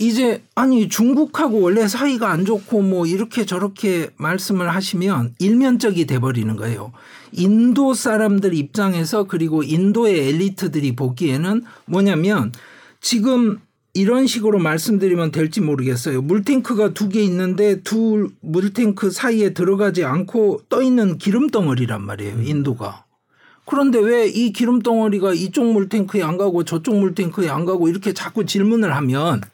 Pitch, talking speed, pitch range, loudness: 195 Hz, 330 characters per minute, 165-220 Hz, -18 LUFS